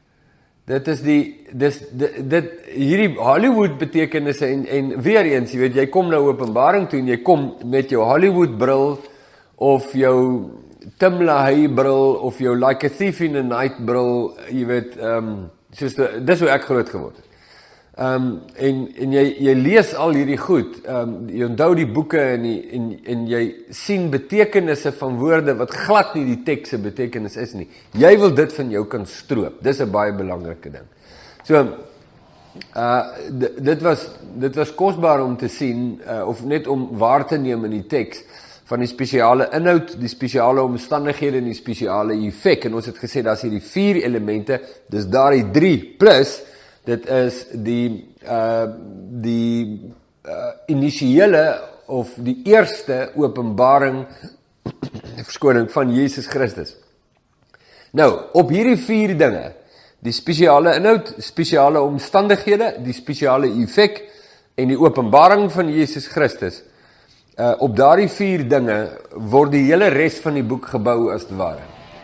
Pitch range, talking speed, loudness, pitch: 120-155 Hz, 160 wpm, -18 LUFS, 135 Hz